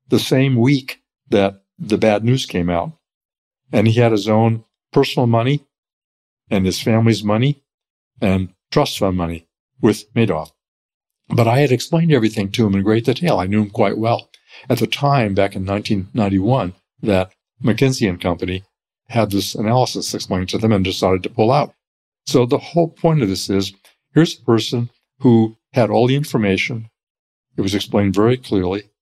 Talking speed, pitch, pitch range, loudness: 170 wpm, 110 Hz, 100-125 Hz, -18 LUFS